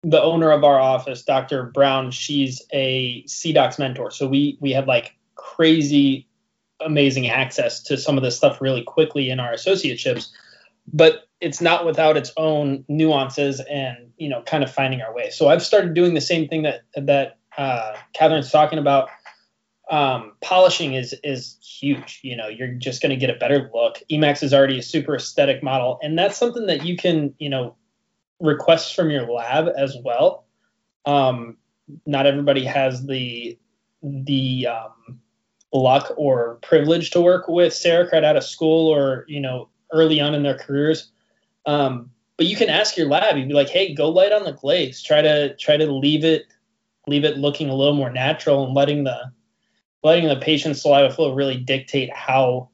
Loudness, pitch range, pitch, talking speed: -19 LUFS, 130-160 Hz, 145 Hz, 180 wpm